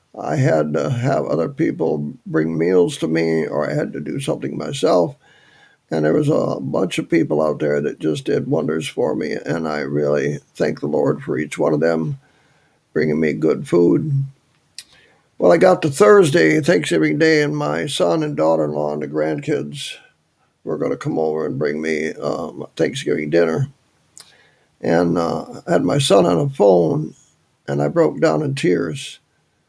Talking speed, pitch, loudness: 180 wpm, 80 Hz, -18 LUFS